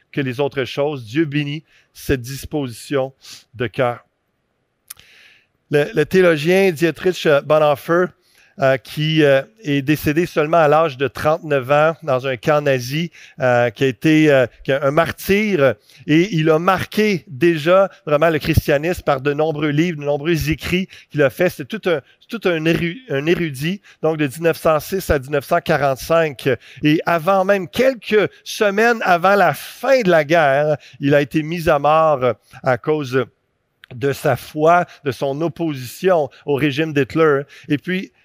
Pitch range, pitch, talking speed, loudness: 140-170 Hz, 155 Hz, 145 wpm, -17 LUFS